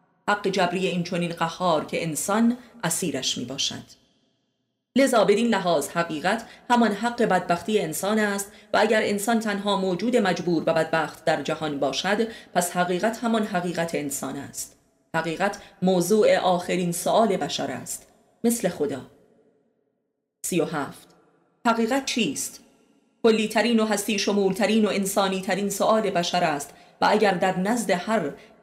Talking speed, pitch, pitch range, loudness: 140 wpm, 200 Hz, 175-220 Hz, -24 LUFS